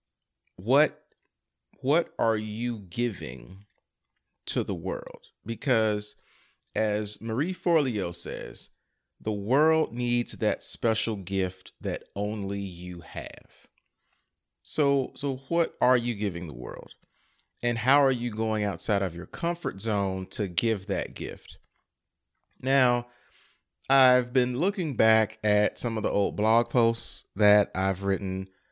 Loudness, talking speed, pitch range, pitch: -27 LUFS, 125 wpm, 100-125 Hz, 110 Hz